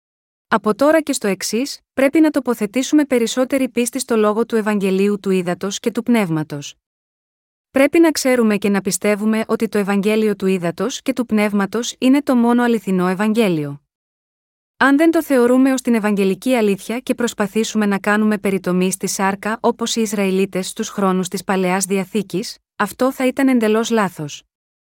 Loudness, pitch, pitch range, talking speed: -17 LUFS, 215 Hz, 195-245 Hz, 160 wpm